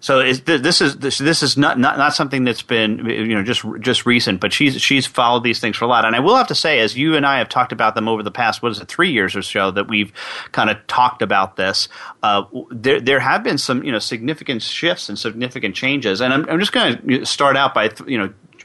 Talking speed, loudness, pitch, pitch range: 265 wpm, -17 LUFS, 125 Hz, 110-140 Hz